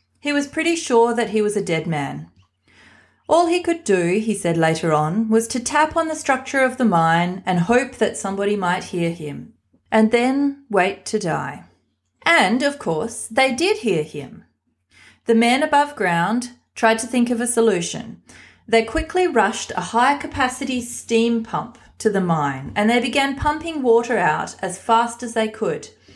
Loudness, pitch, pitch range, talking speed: -19 LUFS, 230 Hz, 185-265 Hz, 180 wpm